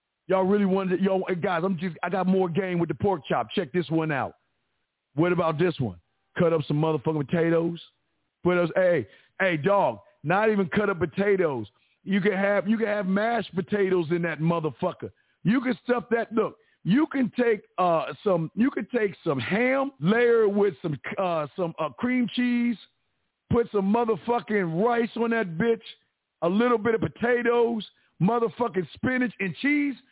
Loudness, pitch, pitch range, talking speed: -25 LUFS, 195 Hz, 175-230 Hz, 175 wpm